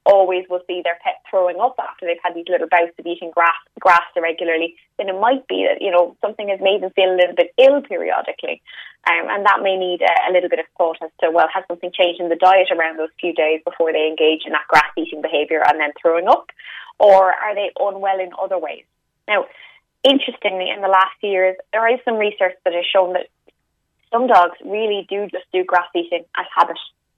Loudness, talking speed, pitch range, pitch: -18 LUFS, 225 wpm, 170-195 Hz, 180 Hz